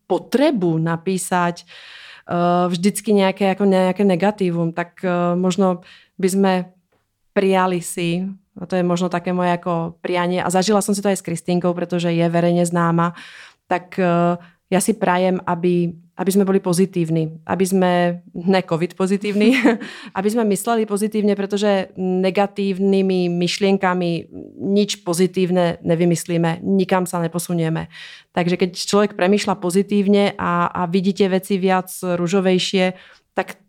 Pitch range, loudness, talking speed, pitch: 175-195 Hz, -19 LUFS, 135 wpm, 185 Hz